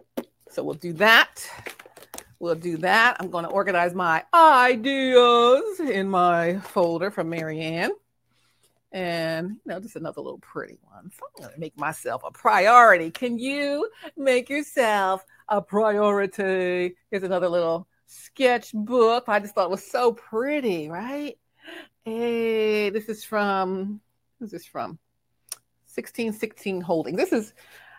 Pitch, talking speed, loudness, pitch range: 205 Hz, 135 wpm, -22 LUFS, 180-240 Hz